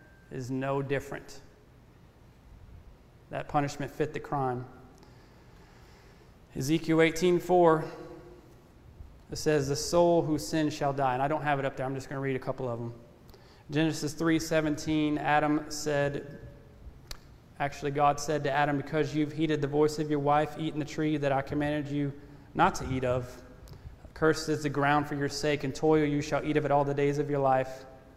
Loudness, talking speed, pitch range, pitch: -29 LUFS, 180 wpm, 135-150 Hz, 145 Hz